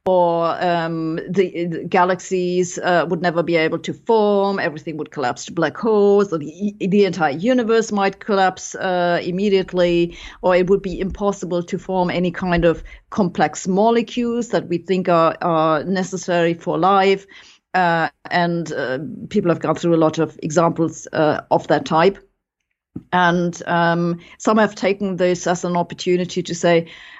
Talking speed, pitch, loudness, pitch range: 160 wpm, 180 Hz, -19 LUFS, 170-195 Hz